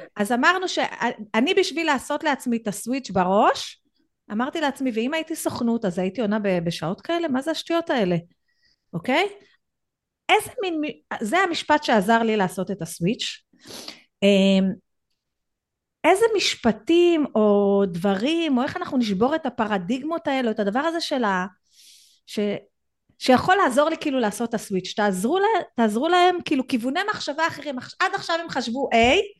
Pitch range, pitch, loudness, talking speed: 210-330 Hz, 260 Hz, -22 LUFS, 140 wpm